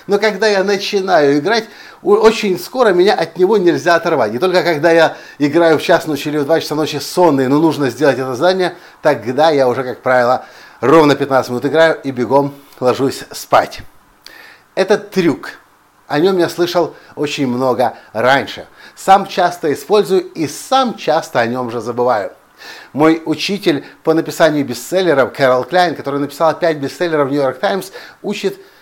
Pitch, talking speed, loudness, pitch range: 160 Hz, 165 wpm, -14 LUFS, 140-190 Hz